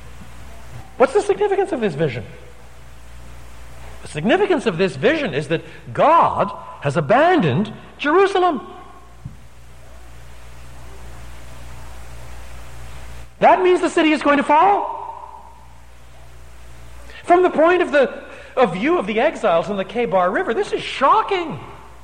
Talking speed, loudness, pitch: 115 wpm, -17 LUFS, 150 Hz